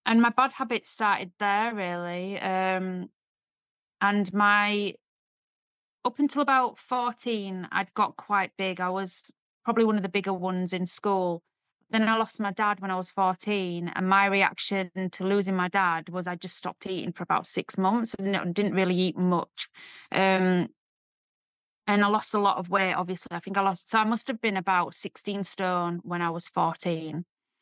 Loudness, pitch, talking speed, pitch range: -27 LUFS, 195 Hz, 180 wpm, 185-205 Hz